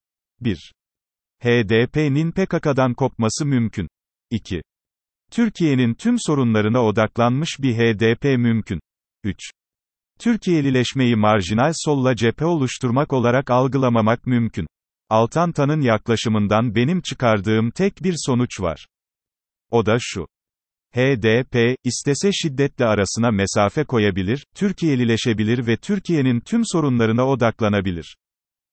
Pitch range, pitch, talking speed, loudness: 110-145 Hz, 120 Hz, 95 wpm, -19 LUFS